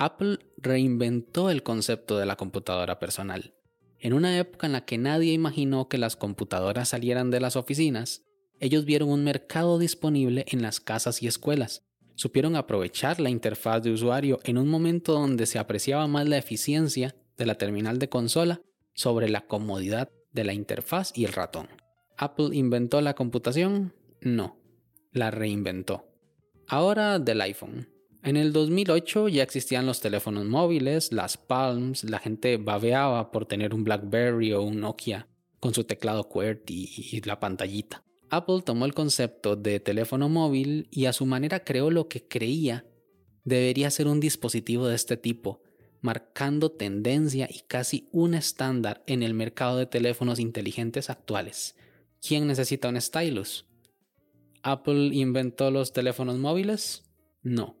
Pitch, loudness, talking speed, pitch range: 125 Hz, -27 LUFS, 150 wpm, 110-145 Hz